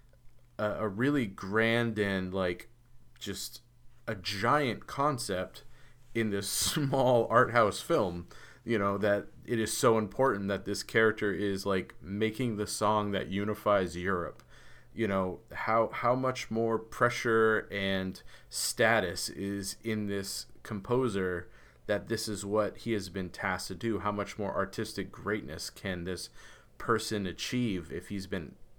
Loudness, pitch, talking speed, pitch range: -31 LUFS, 105 Hz, 140 wpm, 100-115 Hz